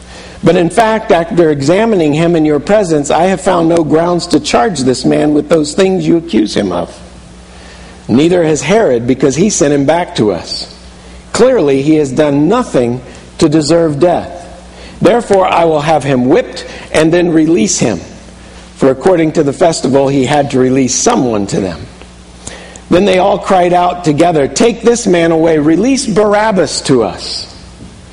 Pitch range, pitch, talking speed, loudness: 130-175 Hz, 155 Hz, 170 wpm, -10 LUFS